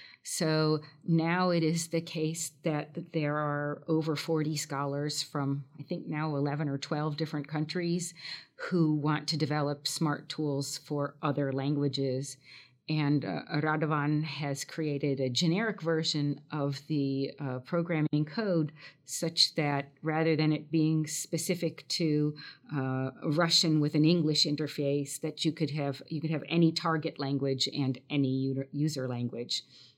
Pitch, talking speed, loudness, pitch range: 150 Hz, 140 wpm, -31 LUFS, 140-160 Hz